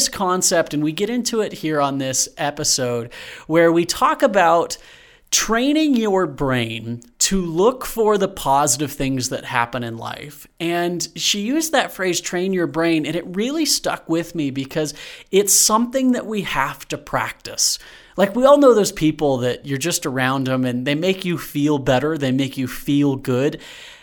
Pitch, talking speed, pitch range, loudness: 165 Hz, 175 wpm, 140-205 Hz, -19 LUFS